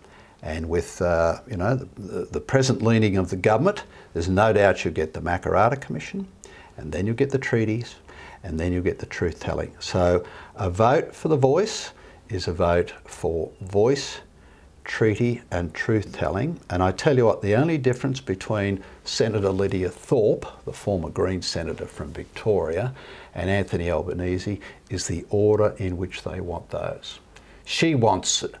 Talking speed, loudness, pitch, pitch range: 170 wpm, -24 LUFS, 95 Hz, 90-110 Hz